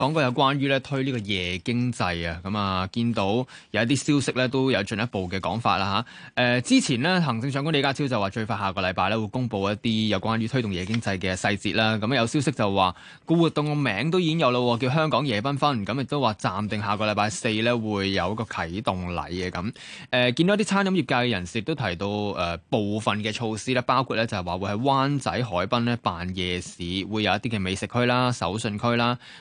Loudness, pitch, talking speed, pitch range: -25 LUFS, 115 Hz, 335 characters per minute, 100-130 Hz